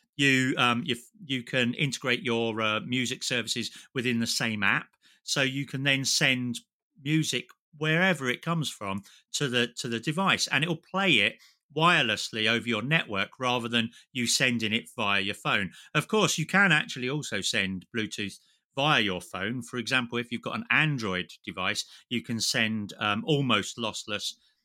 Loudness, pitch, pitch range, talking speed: -27 LUFS, 125 Hz, 115-145 Hz, 175 wpm